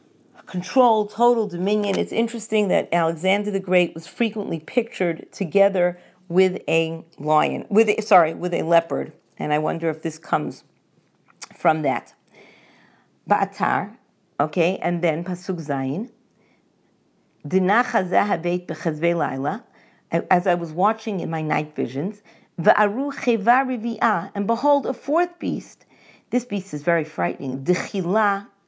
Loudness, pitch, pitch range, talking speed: -22 LUFS, 185 Hz, 165-220 Hz, 115 wpm